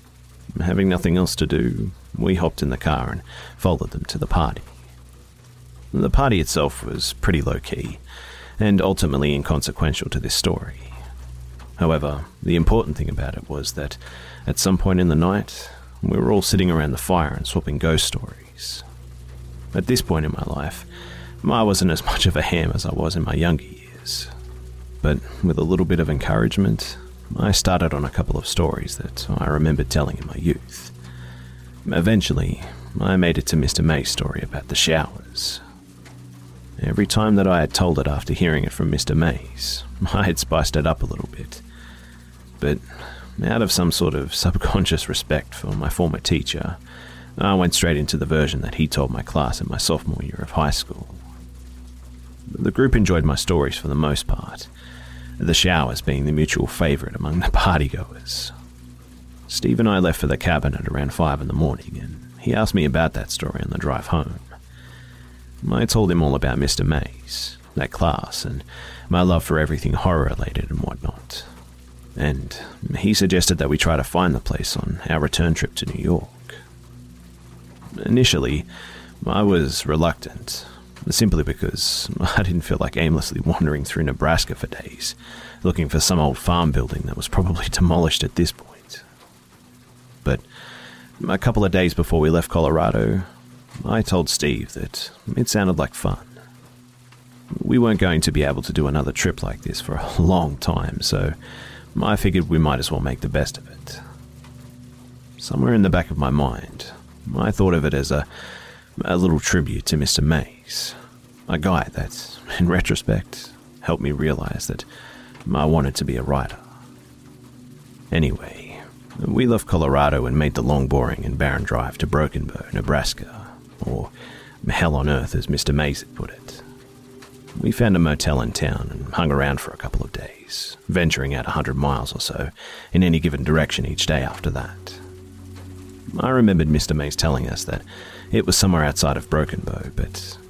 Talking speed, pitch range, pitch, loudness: 175 wpm, 60-90 Hz, 75 Hz, -21 LUFS